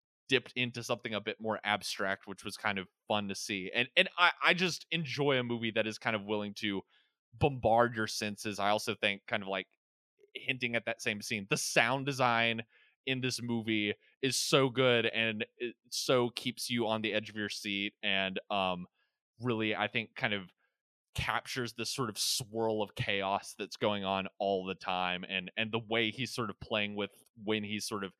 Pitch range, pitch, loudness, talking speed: 105-120 Hz, 110 Hz, -33 LUFS, 200 wpm